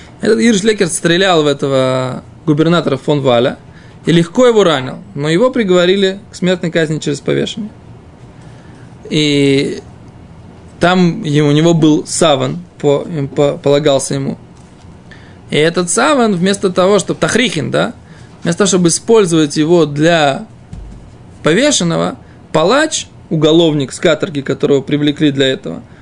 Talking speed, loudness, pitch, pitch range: 120 wpm, -12 LUFS, 160 Hz, 145-185 Hz